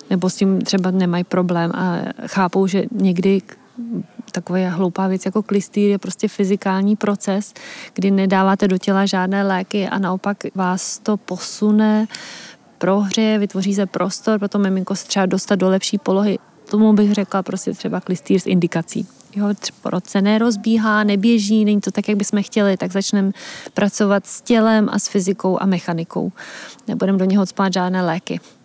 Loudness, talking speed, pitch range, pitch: -18 LUFS, 155 wpm, 190-210 Hz, 195 Hz